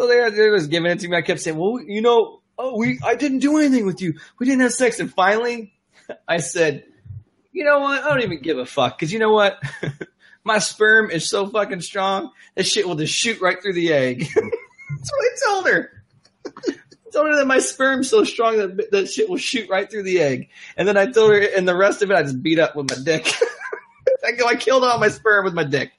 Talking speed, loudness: 240 wpm, -19 LUFS